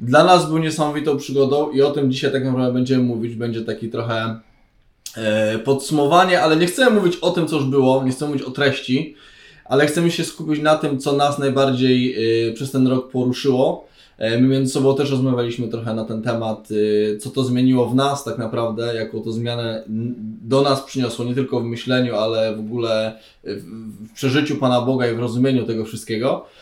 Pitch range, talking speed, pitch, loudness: 115-140 Hz, 185 wpm, 130 Hz, -19 LUFS